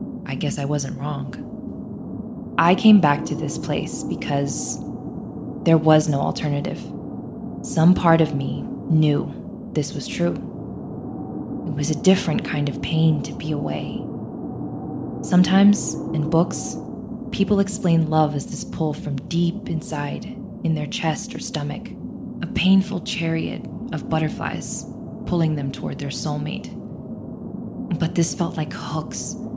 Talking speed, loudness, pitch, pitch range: 135 wpm, -23 LUFS, 165 Hz, 150-195 Hz